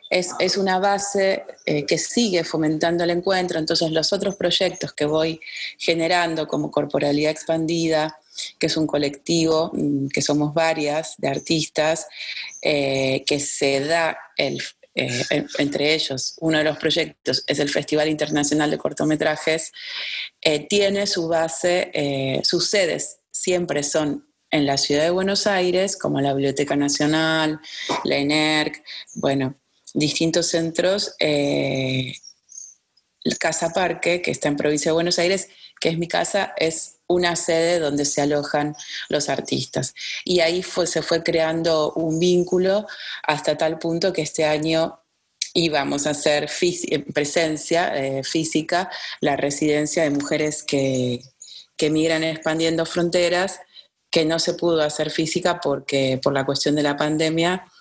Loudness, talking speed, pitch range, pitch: -21 LUFS, 140 wpm, 150-175 Hz, 160 Hz